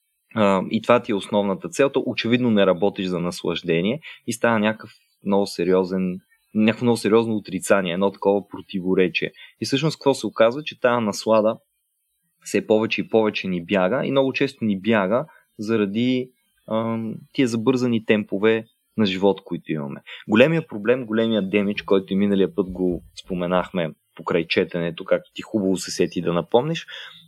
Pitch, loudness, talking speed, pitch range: 110 Hz, -22 LUFS, 150 wpm, 95-120 Hz